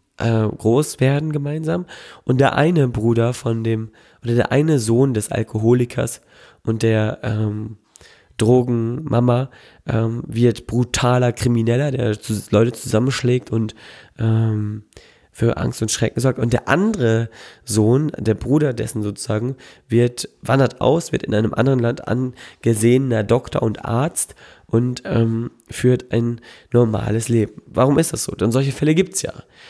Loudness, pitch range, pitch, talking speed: -19 LUFS, 110-130 Hz, 120 Hz, 145 wpm